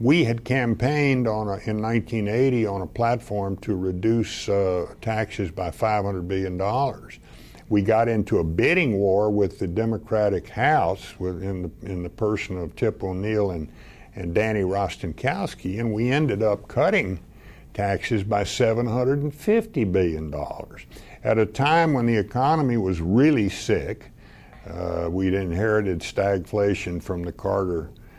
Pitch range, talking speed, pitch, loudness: 95-115 Hz, 135 wpm, 105 Hz, -24 LUFS